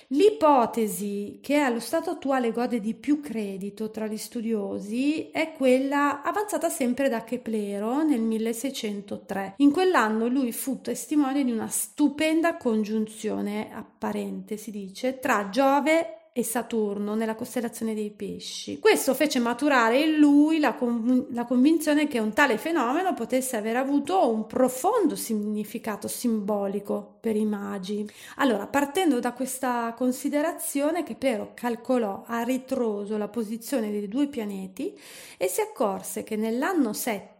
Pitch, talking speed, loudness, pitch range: 245 Hz, 135 wpm, -26 LUFS, 220-285 Hz